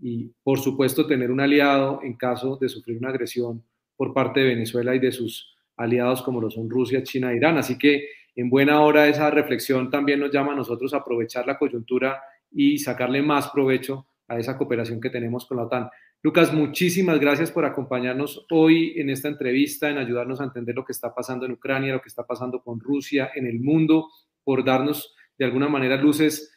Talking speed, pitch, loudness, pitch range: 200 wpm, 135 Hz, -23 LUFS, 125-145 Hz